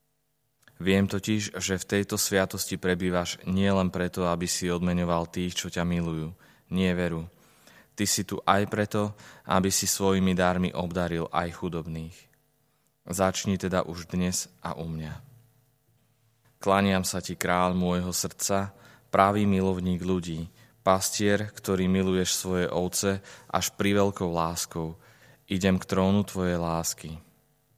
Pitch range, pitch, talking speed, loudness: 90-100 Hz, 95 Hz, 130 wpm, -27 LUFS